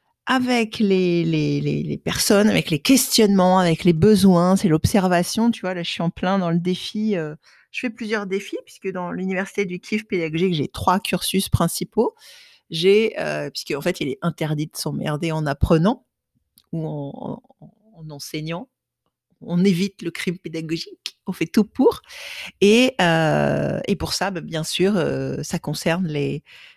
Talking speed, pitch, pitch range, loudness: 170 wpm, 180 Hz, 160-210 Hz, -21 LUFS